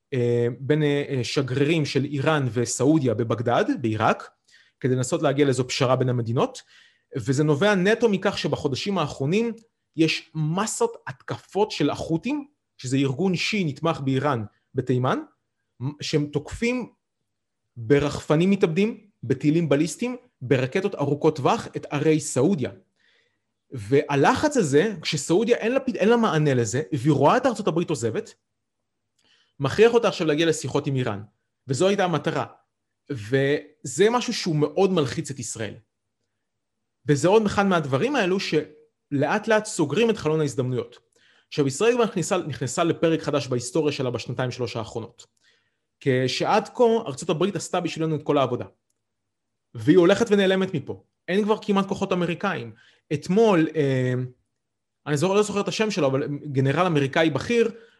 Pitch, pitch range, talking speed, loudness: 150 Hz, 130-190 Hz, 130 wpm, -23 LUFS